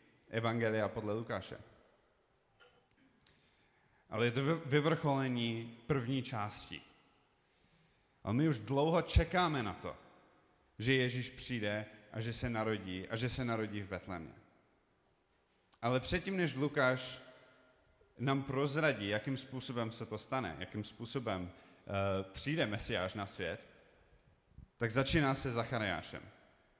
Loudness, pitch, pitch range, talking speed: -37 LUFS, 120 Hz, 105-135 Hz, 115 wpm